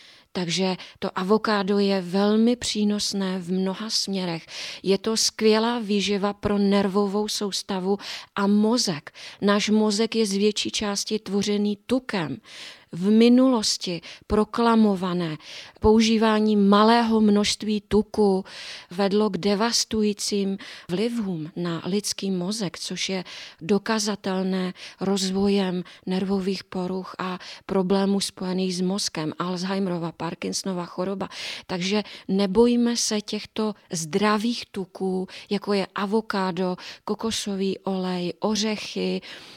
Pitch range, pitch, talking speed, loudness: 185-215 Hz, 200 Hz, 100 wpm, -24 LUFS